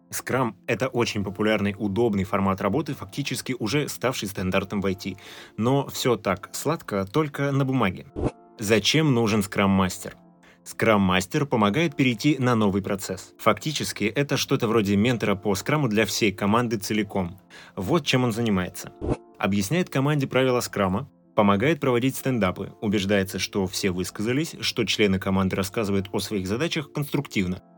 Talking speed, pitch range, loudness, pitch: 140 wpm, 100-130 Hz, -24 LUFS, 110 Hz